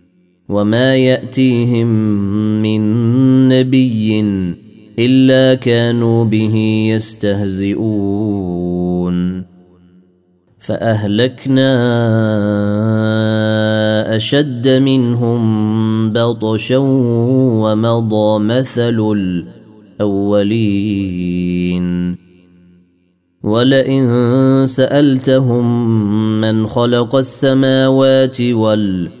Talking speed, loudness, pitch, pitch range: 45 wpm, -13 LUFS, 110 Hz, 100-120 Hz